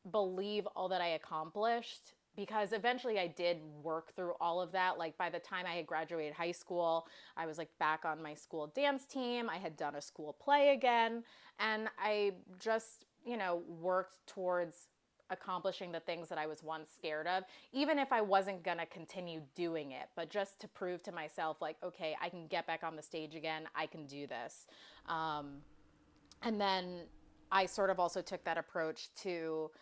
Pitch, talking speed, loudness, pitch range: 175 Hz, 190 wpm, -39 LUFS, 160-195 Hz